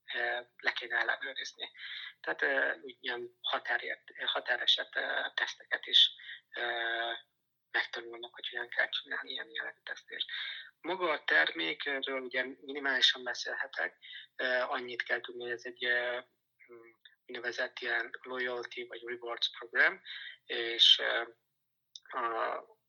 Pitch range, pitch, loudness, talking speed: 120-135 Hz, 125 Hz, -32 LUFS, 95 wpm